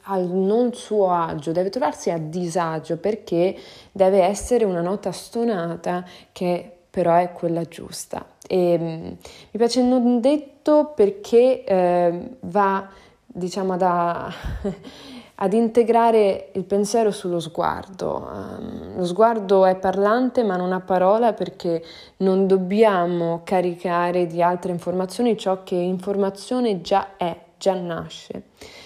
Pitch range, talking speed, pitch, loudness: 175-220 Hz, 120 wpm, 190 Hz, -21 LUFS